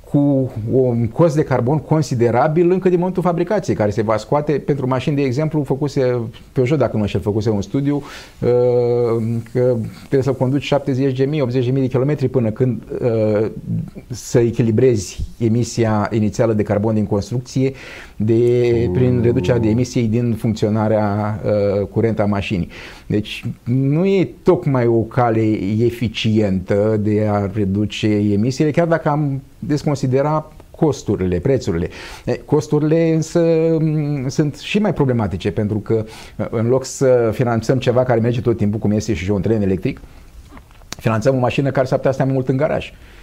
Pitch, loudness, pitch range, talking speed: 125 Hz, -18 LUFS, 110-140 Hz, 145 wpm